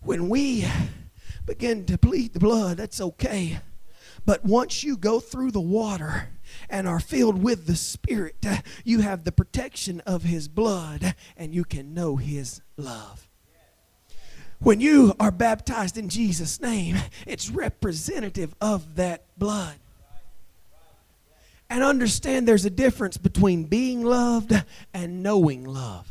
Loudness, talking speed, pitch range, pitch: -24 LUFS, 135 wpm, 170-225 Hz, 195 Hz